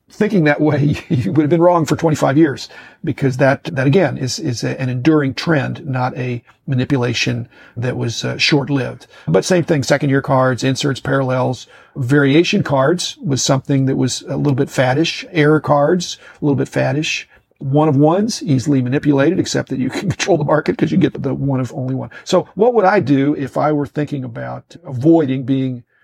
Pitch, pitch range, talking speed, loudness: 140 Hz, 130-155 Hz, 195 wpm, -16 LUFS